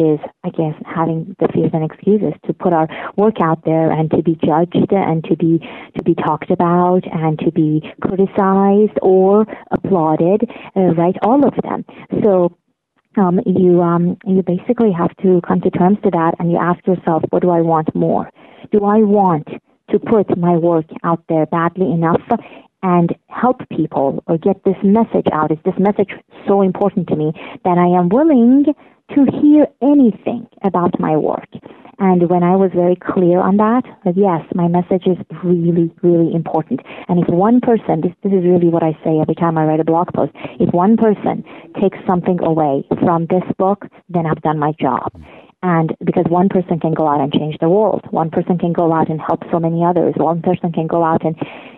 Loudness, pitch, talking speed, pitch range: -15 LUFS, 180 Hz, 195 wpm, 165-195 Hz